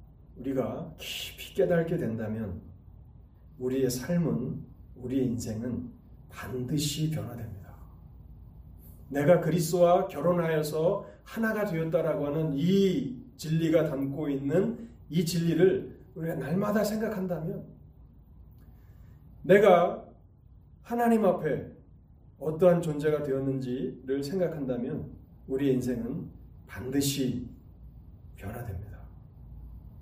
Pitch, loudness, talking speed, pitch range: 135 Hz, -29 LUFS, 220 characters per minute, 110-170 Hz